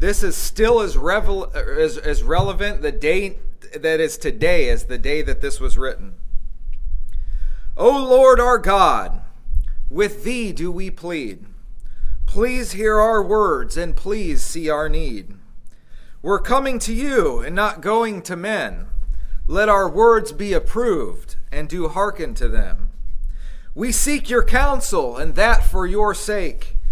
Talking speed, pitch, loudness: 145 wpm, 200 Hz, -20 LUFS